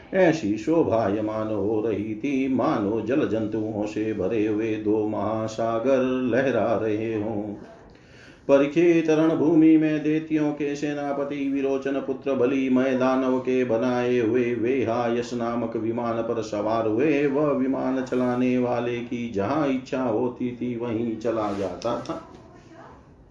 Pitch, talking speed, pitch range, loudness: 125 Hz, 125 wpm, 110-135 Hz, -24 LUFS